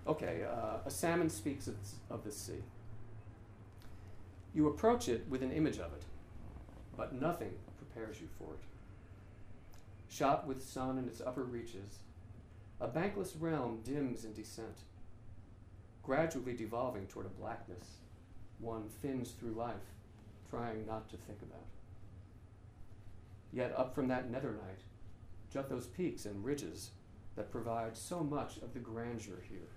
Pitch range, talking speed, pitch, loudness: 100-120 Hz, 135 wpm, 110 Hz, -41 LUFS